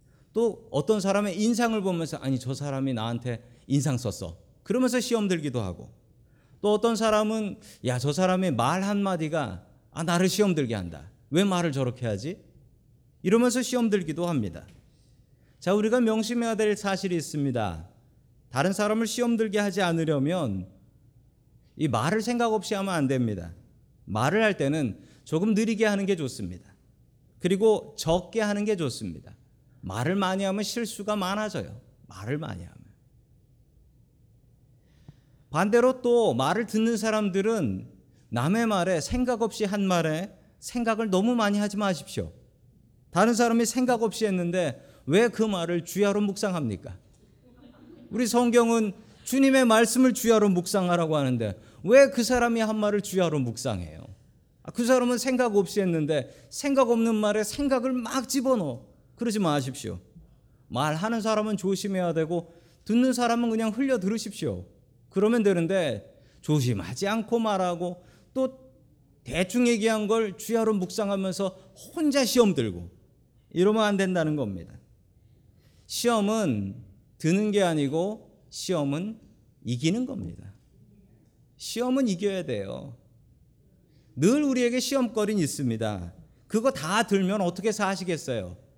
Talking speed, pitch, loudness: 290 characters per minute, 180 Hz, -26 LUFS